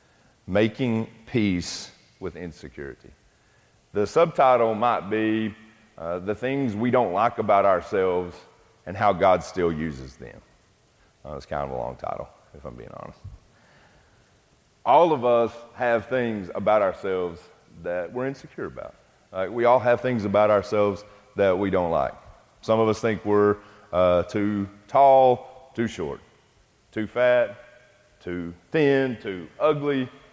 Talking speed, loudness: 140 wpm, -23 LUFS